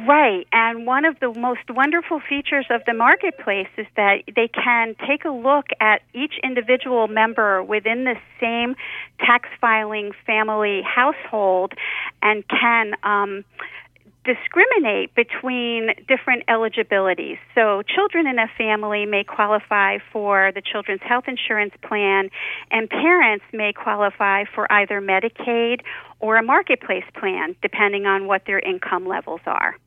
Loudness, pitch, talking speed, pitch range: -19 LUFS, 225 Hz, 135 wpm, 205-255 Hz